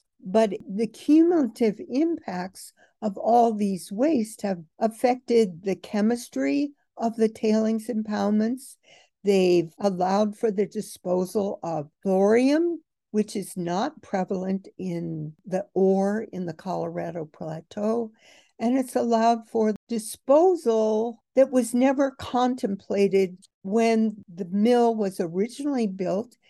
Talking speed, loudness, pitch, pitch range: 110 wpm, -25 LUFS, 215 Hz, 195-235 Hz